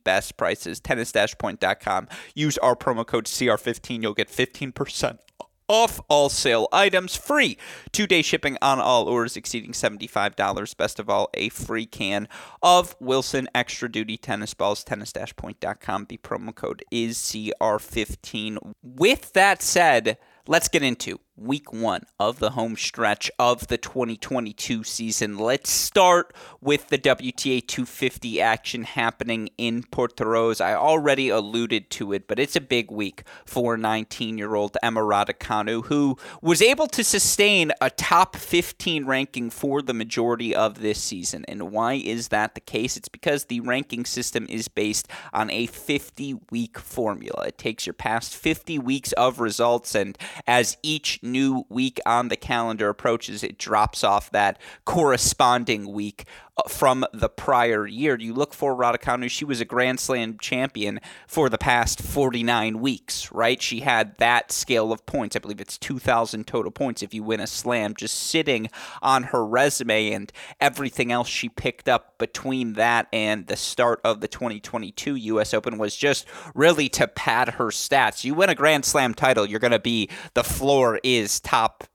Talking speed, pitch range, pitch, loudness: 160 wpm, 110-135 Hz, 120 Hz, -23 LUFS